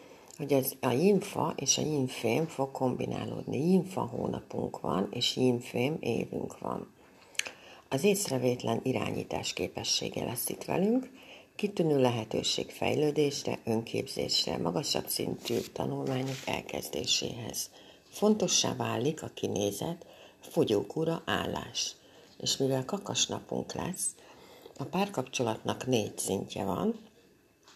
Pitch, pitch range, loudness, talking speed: 140 Hz, 125-185 Hz, -31 LUFS, 100 wpm